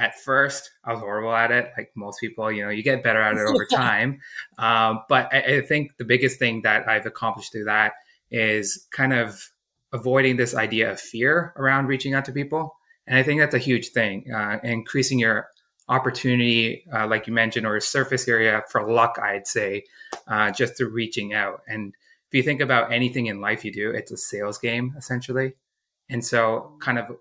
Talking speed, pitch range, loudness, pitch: 205 wpm, 110-130 Hz, -22 LUFS, 115 Hz